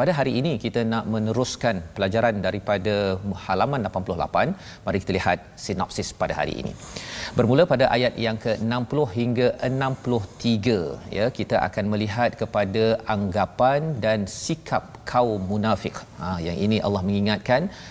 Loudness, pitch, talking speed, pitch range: -24 LUFS, 110 Hz, 135 wpm, 100-120 Hz